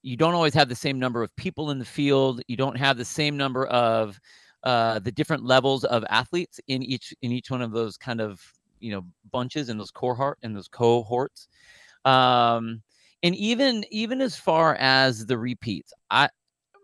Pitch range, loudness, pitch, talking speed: 120-145 Hz, -24 LUFS, 130 Hz, 190 wpm